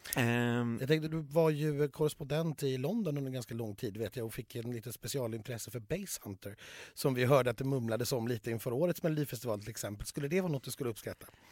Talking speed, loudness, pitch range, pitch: 215 wpm, -35 LUFS, 115-150 Hz, 130 Hz